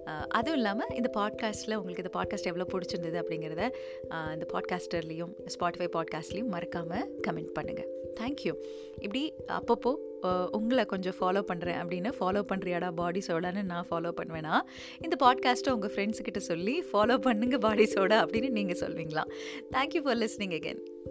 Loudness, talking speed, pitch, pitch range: -32 LUFS, 135 wpm, 195 Hz, 175-245 Hz